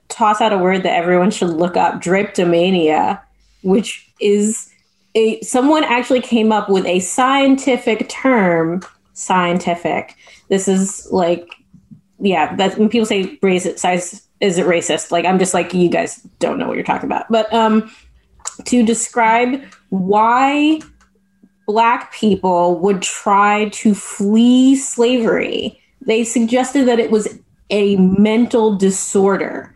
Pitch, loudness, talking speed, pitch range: 205 Hz, -15 LUFS, 135 wpm, 185-235 Hz